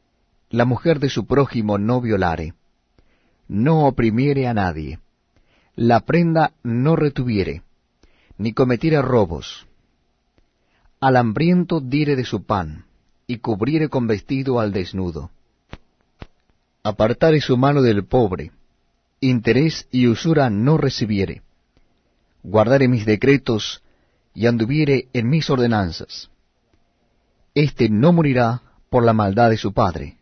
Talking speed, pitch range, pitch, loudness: 115 wpm, 100-135 Hz, 120 Hz, -19 LUFS